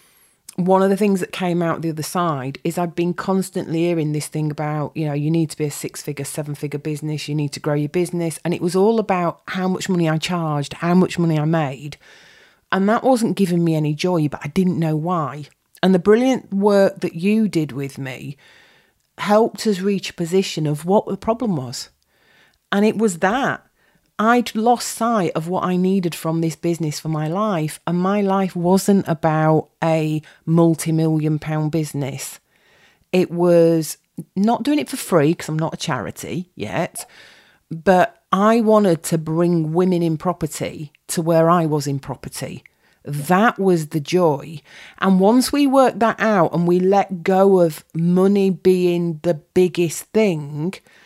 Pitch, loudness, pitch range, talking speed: 170 Hz, -19 LUFS, 155-190 Hz, 185 wpm